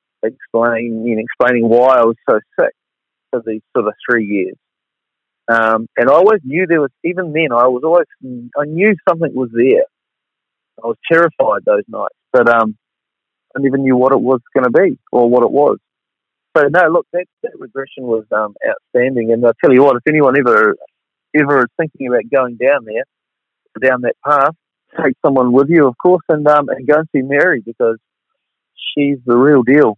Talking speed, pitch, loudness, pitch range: 195 wpm, 130 Hz, -13 LUFS, 120-160 Hz